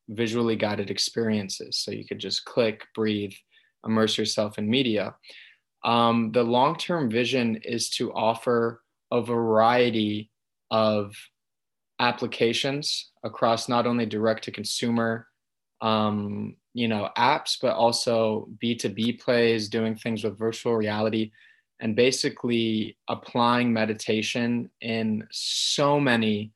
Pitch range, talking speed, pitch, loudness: 110-120 Hz, 110 wpm, 115 Hz, -25 LUFS